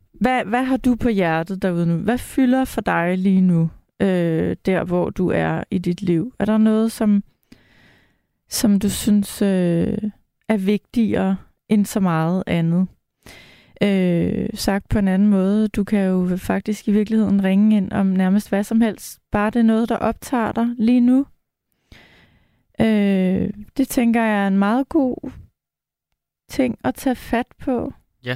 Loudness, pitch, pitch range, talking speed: -19 LUFS, 205 Hz, 190-230 Hz, 165 wpm